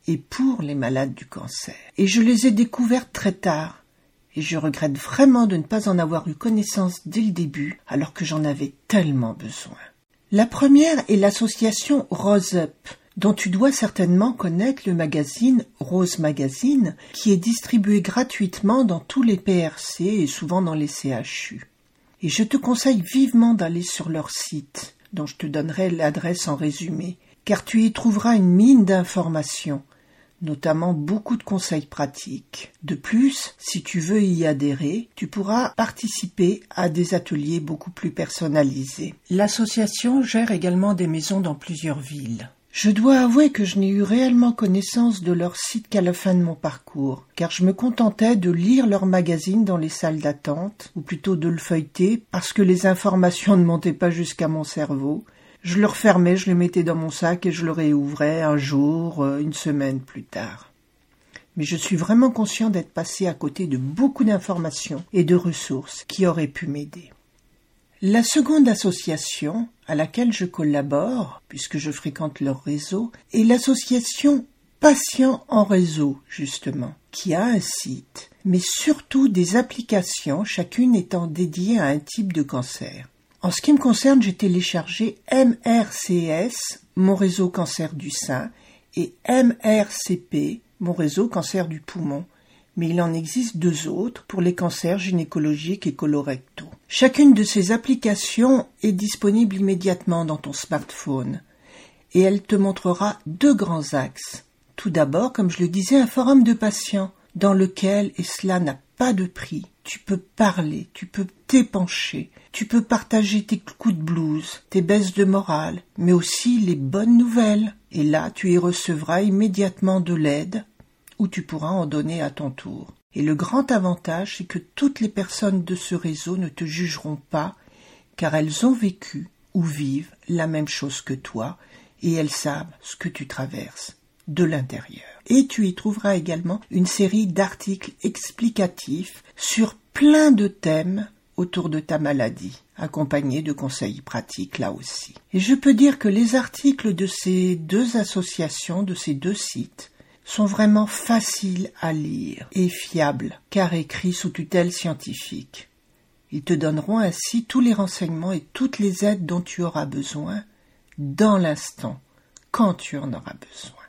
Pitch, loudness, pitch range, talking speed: 180 Hz, -21 LUFS, 155-215 Hz, 160 wpm